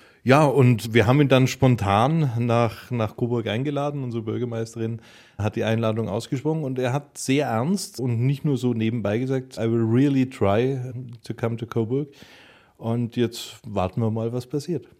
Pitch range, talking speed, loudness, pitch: 115-135 Hz, 170 wpm, -23 LUFS, 120 Hz